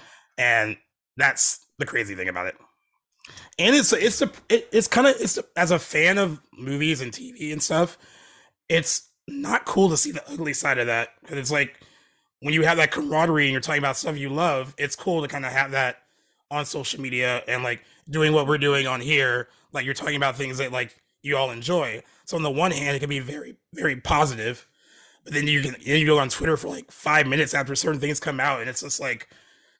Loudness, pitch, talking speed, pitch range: -23 LUFS, 145 Hz, 225 wpm, 135-160 Hz